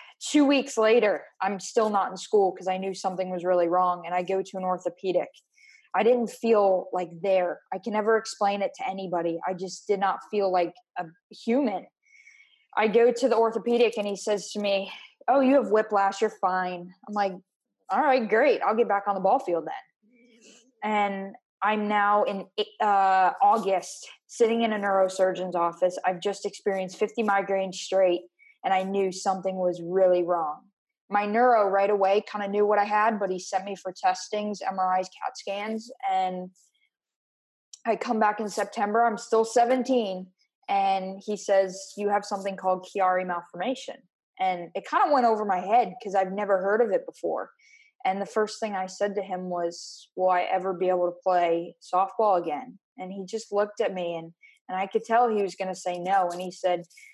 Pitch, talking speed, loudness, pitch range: 200 Hz, 195 wpm, -26 LUFS, 185-230 Hz